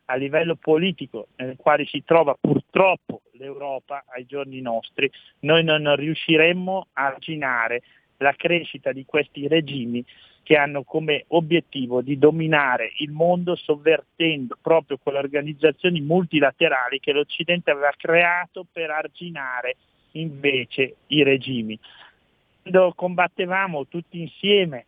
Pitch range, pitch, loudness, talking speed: 140-170 Hz, 155 Hz, -21 LUFS, 115 wpm